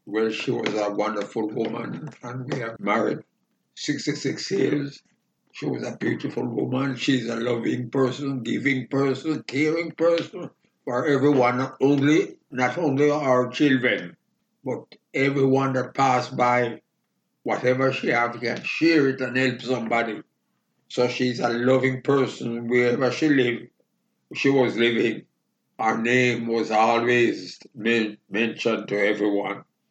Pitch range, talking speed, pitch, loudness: 115-135 Hz, 140 wpm, 125 Hz, -23 LUFS